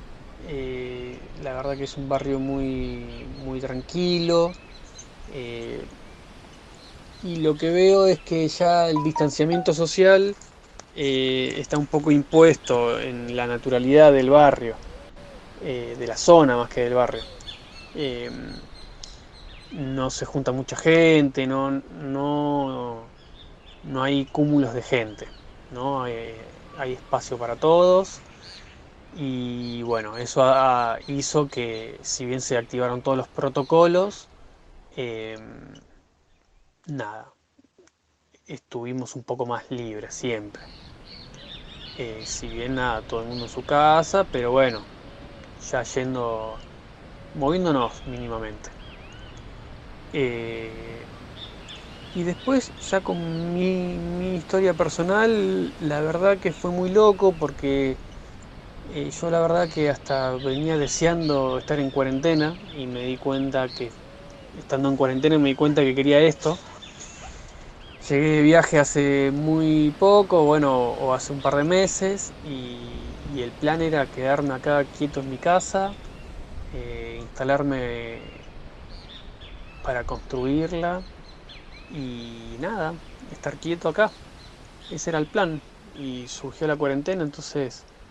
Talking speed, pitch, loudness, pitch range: 120 wpm, 135 Hz, -22 LUFS, 125-160 Hz